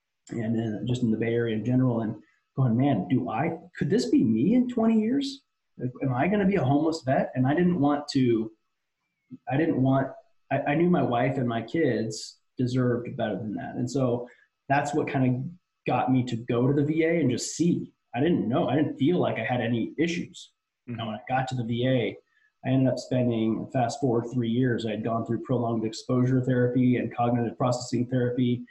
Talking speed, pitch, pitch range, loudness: 215 wpm, 125 Hz, 115-140 Hz, -26 LUFS